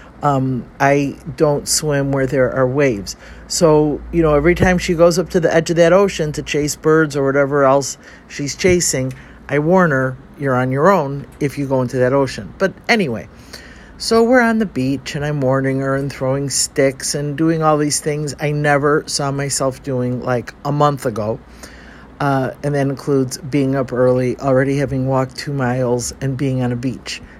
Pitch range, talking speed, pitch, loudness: 130-150 Hz, 195 wpm, 140 Hz, -17 LUFS